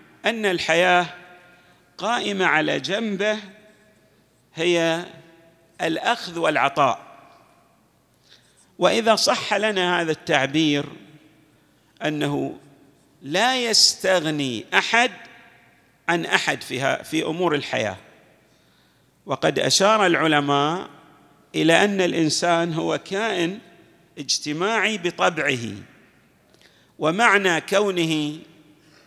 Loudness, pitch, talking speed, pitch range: -21 LUFS, 170 Hz, 70 wpm, 155-200 Hz